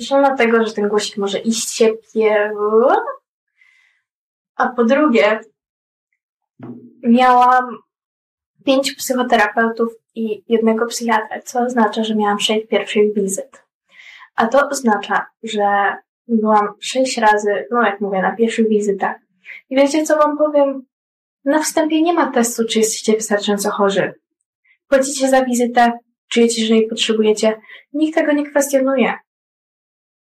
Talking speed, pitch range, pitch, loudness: 125 wpm, 215-270 Hz, 230 Hz, -16 LUFS